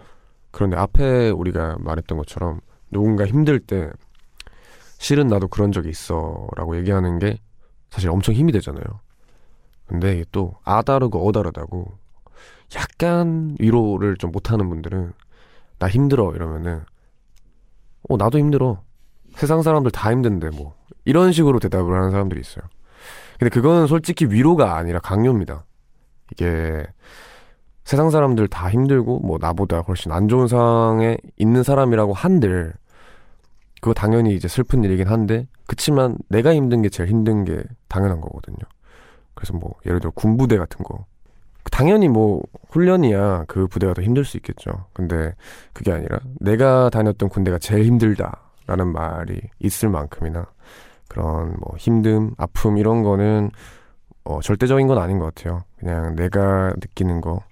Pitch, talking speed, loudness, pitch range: 105 Hz, 305 characters per minute, -19 LUFS, 90-120 Hz